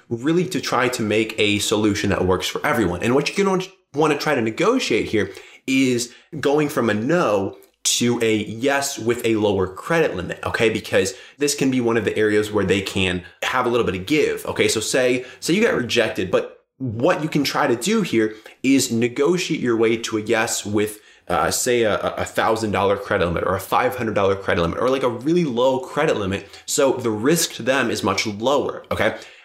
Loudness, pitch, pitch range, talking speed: -20 LUFS, 125 Hz, 110-160 Hz, 215 wpm